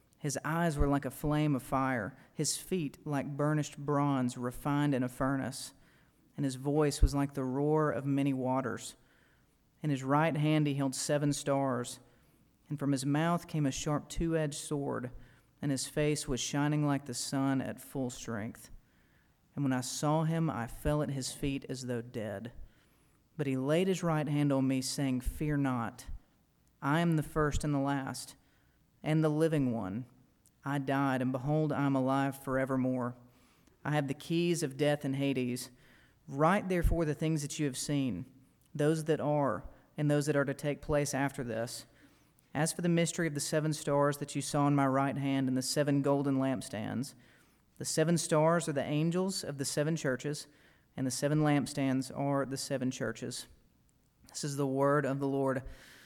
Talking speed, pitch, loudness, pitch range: 185 wpm, 140 Hz, -33 LUFS, 130-150 Hz